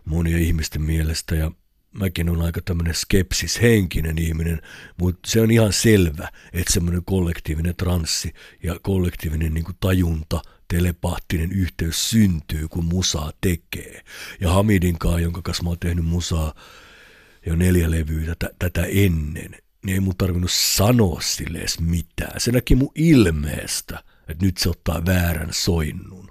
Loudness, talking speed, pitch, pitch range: -21 LUFS, 145 wpm, 85 Hz, 80-95 Hz